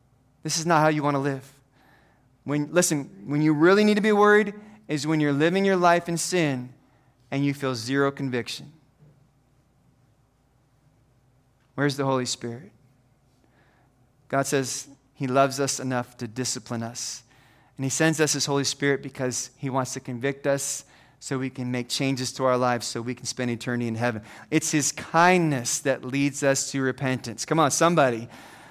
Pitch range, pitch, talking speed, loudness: 125-145 Hz, 135 Hz, 170 wpm, -24 LUFS